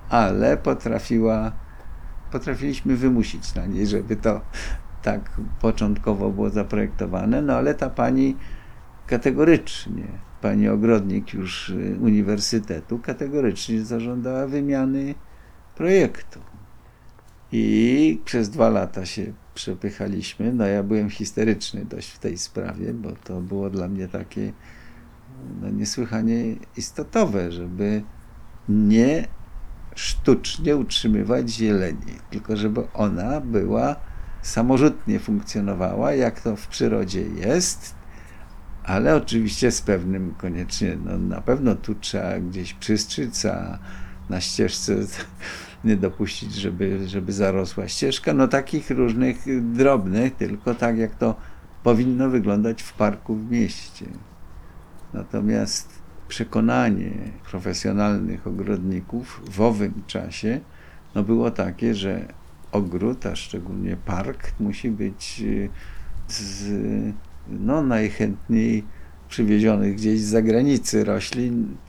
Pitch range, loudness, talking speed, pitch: 95-115 Hz, -23 LUFS, 105 wpm, 105 Hz